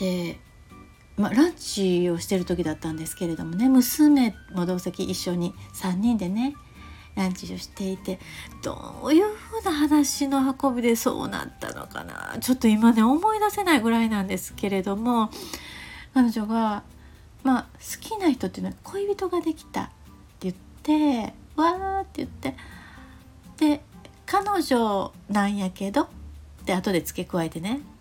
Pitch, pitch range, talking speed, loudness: 225 Hz, 185-295 Hz, 280 characters per minute, -25 LUFS